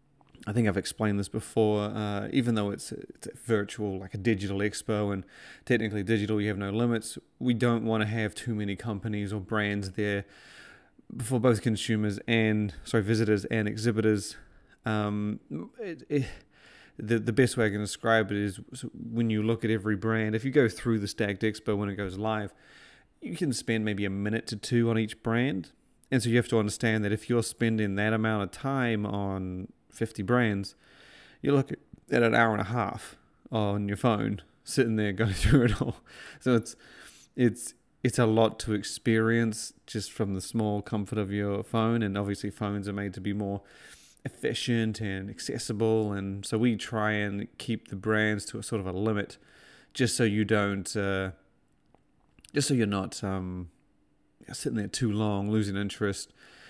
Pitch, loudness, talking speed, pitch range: 110 Hz, -29 LUFS, 185 wpm, 100-115 Hz